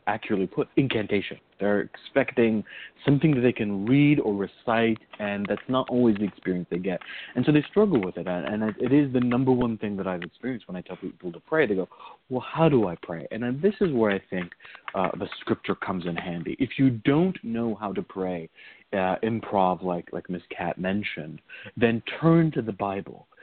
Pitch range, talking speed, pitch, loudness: 95-130 Hz, 205 wpm, 110 Hz, -26 LUFS